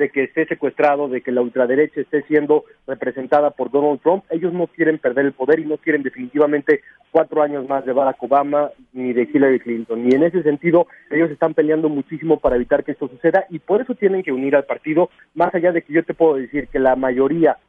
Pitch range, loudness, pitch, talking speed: 135-160 Hz, -18 LUFS, 150 Hz, 225 wpm